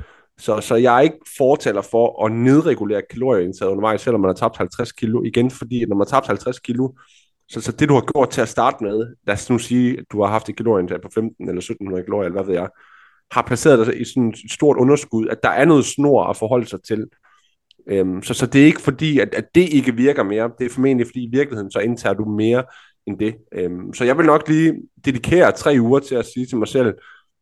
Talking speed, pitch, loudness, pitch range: 245 wpm, 120 Hz, -18 LUFS, 110-130 Hz